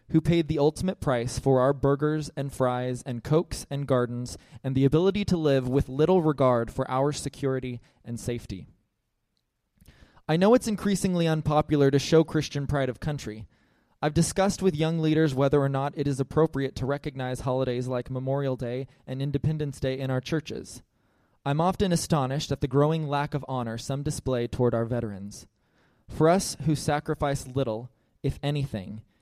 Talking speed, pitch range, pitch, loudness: 170 wpm, 125-155 Hz, 140 Hz, -26 LUFS